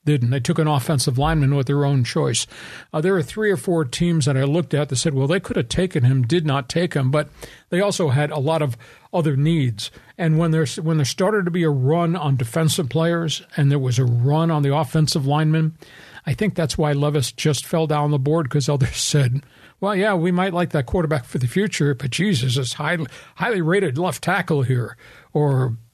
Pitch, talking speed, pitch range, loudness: 155 Hz, 225 wpm, 140-170 Hz, -20 LUFS